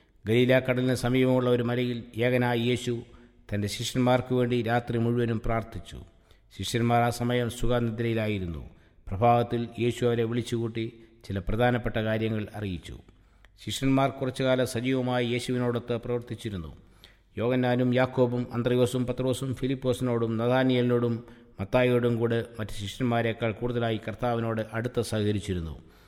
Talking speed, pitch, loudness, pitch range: 95 wpm, 120 Hz, -27 LUFS, 110-125 Hz